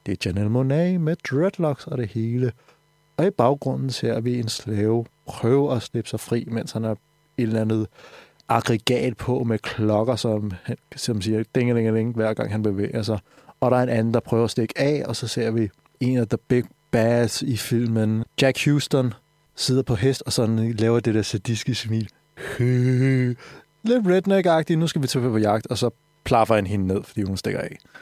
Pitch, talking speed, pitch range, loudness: 120 Hz, 200 wpm, 110-135 Hz, -23 LUFS